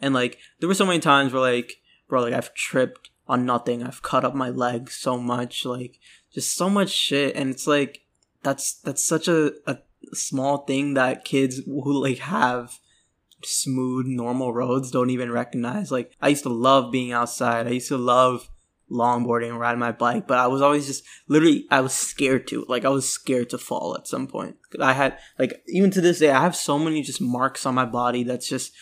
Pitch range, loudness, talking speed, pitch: 125-140 Hz, -23 LUFS, 210 wpm, 130 Hz